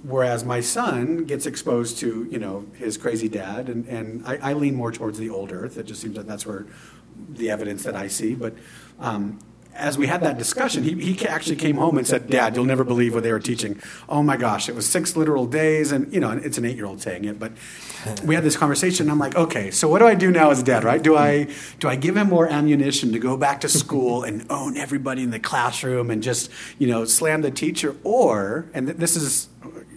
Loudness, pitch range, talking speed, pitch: -21 LUFS, 115-150 Hz, 240 wpm, 130 Hz